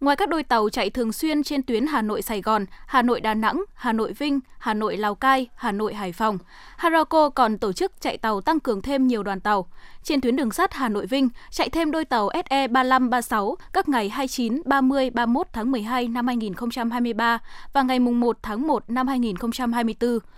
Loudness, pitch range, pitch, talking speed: -23 LUFS, 225-275 Hz, 245 Hz, 205 wpm